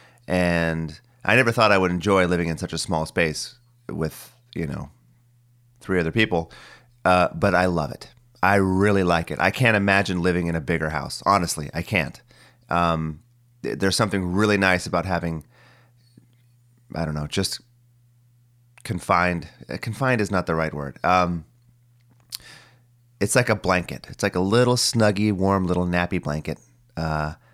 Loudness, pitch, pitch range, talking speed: -22 LUFS, 95 Hz, 85-120 Hz, 155 wpm